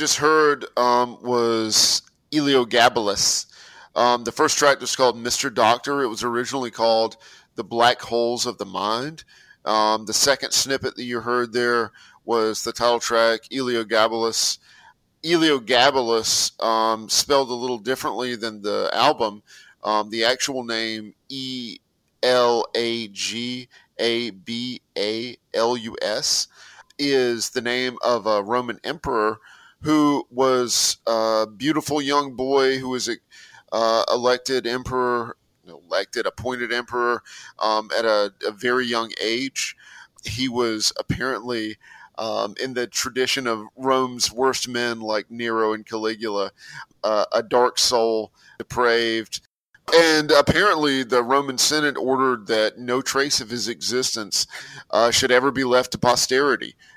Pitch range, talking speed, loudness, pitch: 115-130 Hz, 135 wpm, -21 LUFS, 120 Hz